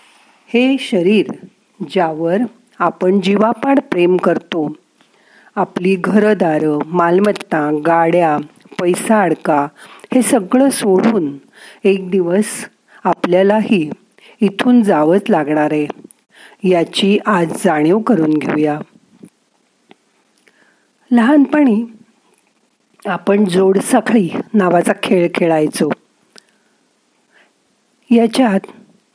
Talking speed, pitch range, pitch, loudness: 70 wpm, 175-230 Hz, 200 Hz, -14 LUFS